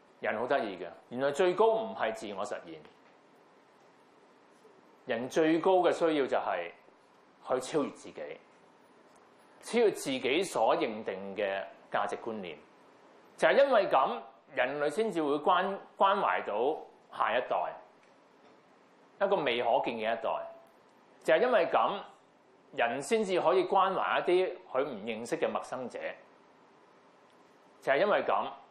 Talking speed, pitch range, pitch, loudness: 195 characters per minute, 160-265 Hz, 190 Hz, -30 LUFS